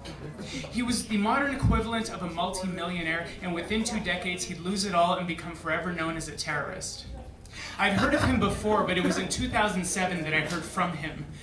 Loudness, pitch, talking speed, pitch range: -28 LUFS, 180 Hz, 200 wpm, 165-200 Hz